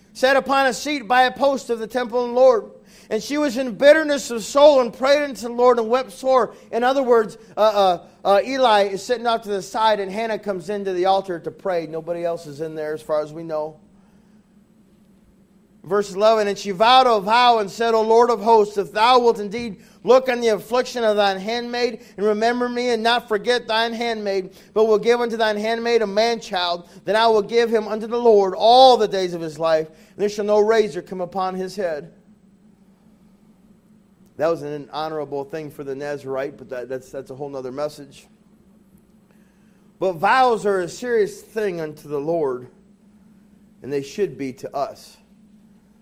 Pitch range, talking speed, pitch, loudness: 190-235 Hz, 200 wpm, 210 Hz, -19 LUFS